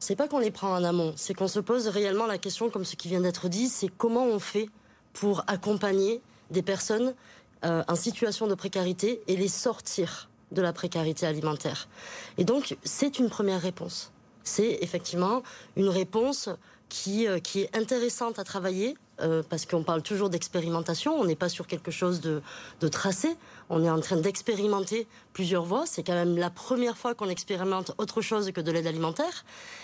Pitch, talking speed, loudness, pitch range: 195 Hz, 190 wpm, -29 LUFS, 175-220 Hz